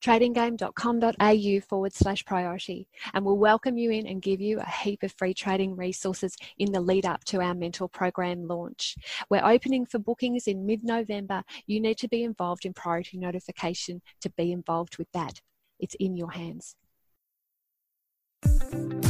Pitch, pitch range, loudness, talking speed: 190 Hz, 180-215 Hz, -28 LUFS, 160 wpm